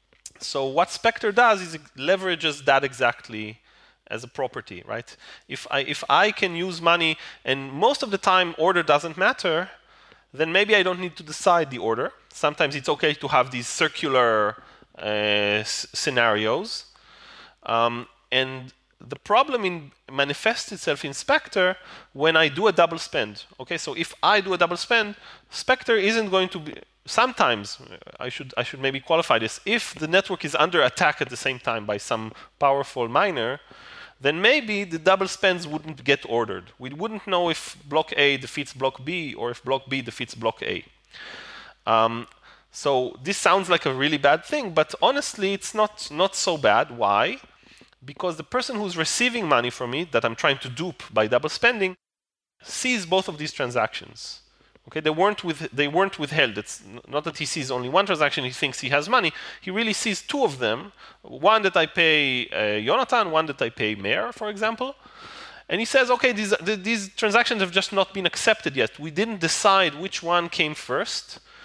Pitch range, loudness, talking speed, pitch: 135-195 Hz, -23 LUFS, 185 wpm, 165 Hz